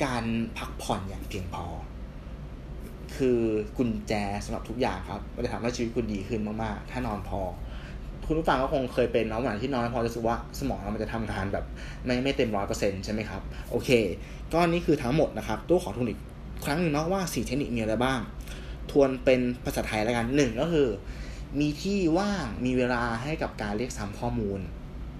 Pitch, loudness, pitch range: 115 Hz, -29 LUFS, 100-130 Hz